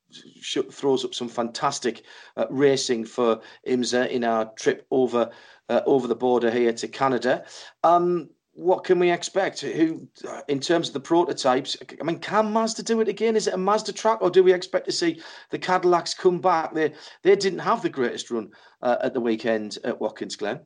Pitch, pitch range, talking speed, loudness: 170 Hz, 125-205 Hz, 190 wpm, -24 LUFS